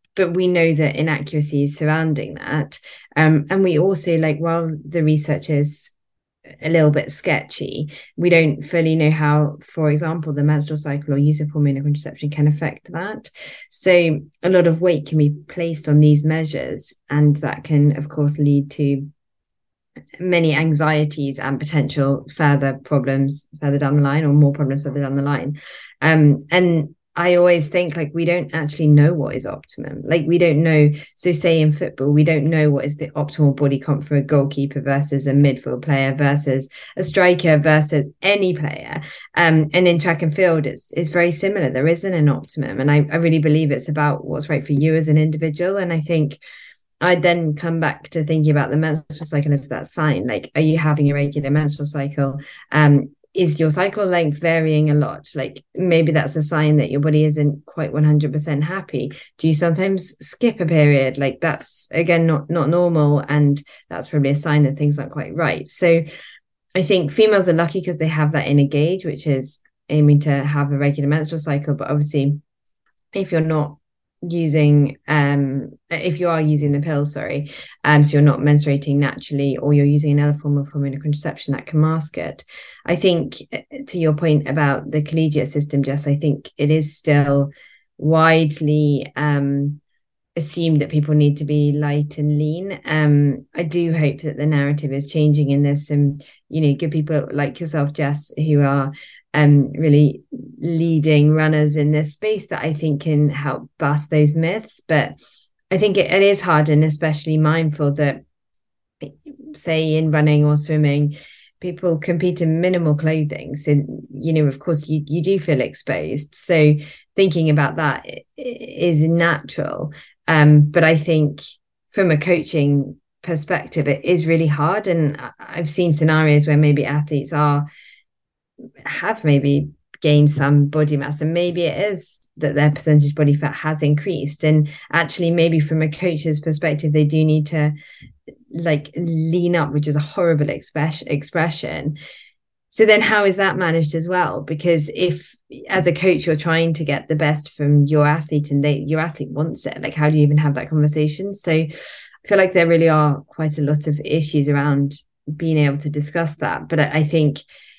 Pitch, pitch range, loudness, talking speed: 150 Hz, 145-165 Hz, -18 LUFS, 185 wpm